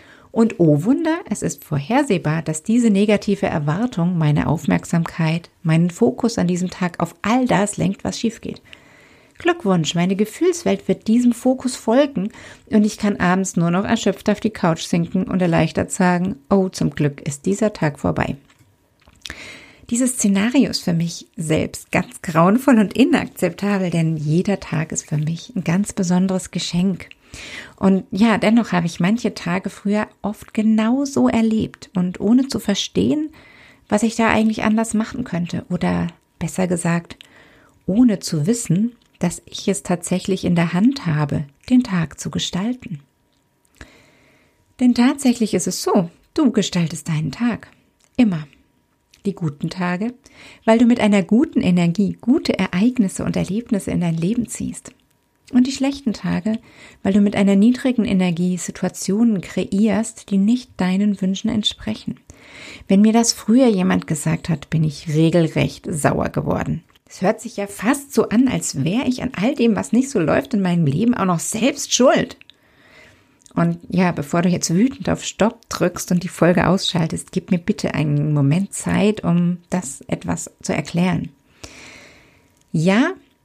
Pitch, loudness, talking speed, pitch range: 195 Hz, -19 LUFS, 155 wpm, 175-225 Hz